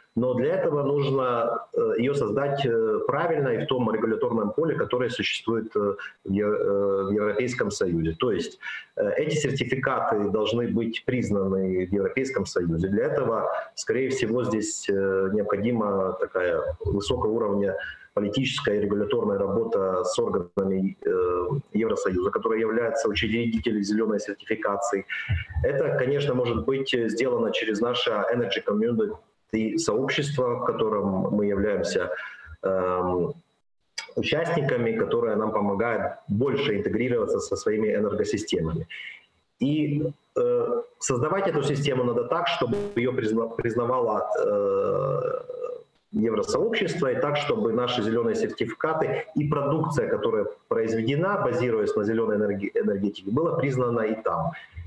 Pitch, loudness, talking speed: 125 Hz, -26 LUFS, 115 wpm